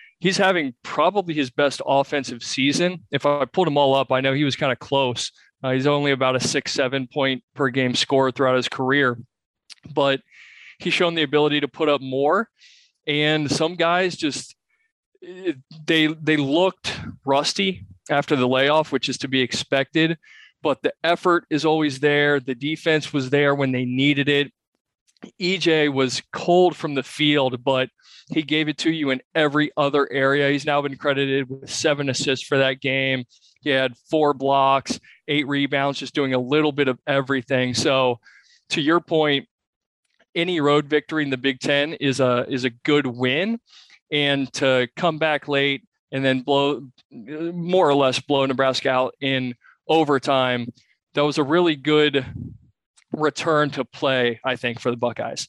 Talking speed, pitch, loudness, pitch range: 170 wpm, 140 Hz, -21 LUFS, 130-155 Hz